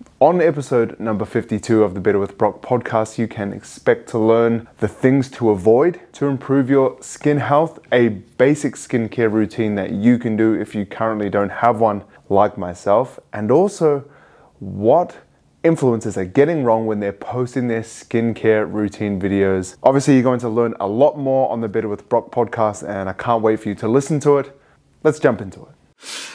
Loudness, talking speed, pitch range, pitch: -18 LUFS, 185 wpm, 105-135 Hz, 115 Hz